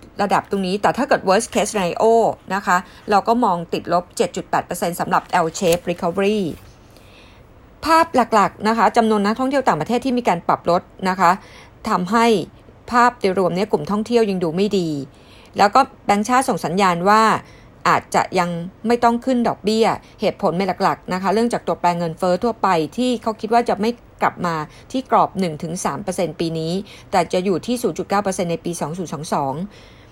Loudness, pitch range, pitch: -19 LUFS, 175-225 Hz, 195 Hz